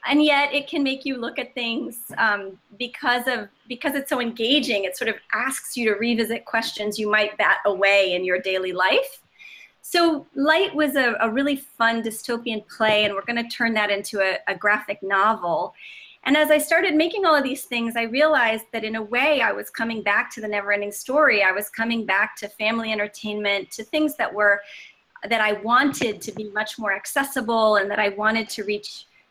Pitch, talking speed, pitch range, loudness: 230 Hz, 205 wpm, 210-275 Hz, -22 LUFS